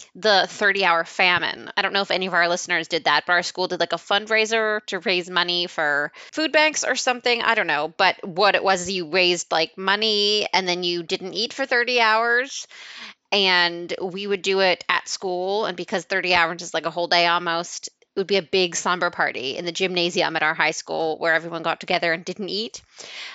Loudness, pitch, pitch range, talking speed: -21 LUFS, 185 Hz, 170-200 Hz, 220 wpm